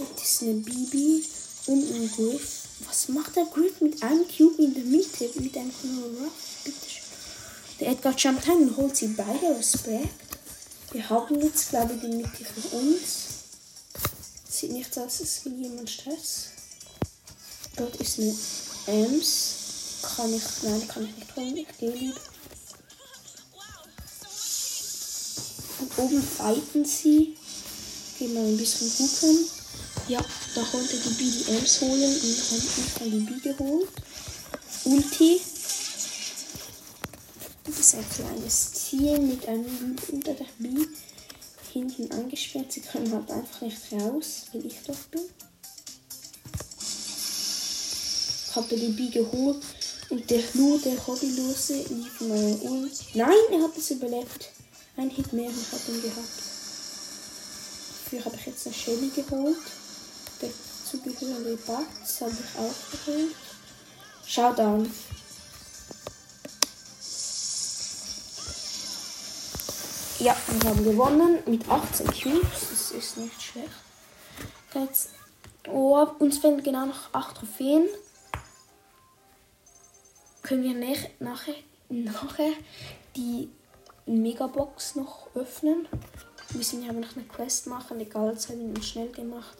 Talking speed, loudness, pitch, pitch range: 125 wpm, -27 LUFS, 260 Hz, 235-295 Hz